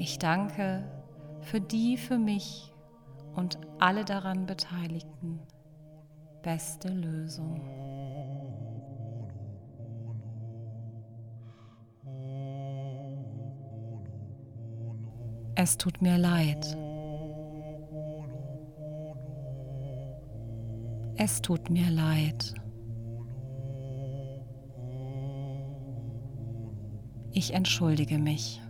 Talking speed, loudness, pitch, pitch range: 50 wpm, -33 LUFS, 135 Hz, 115-155 Hz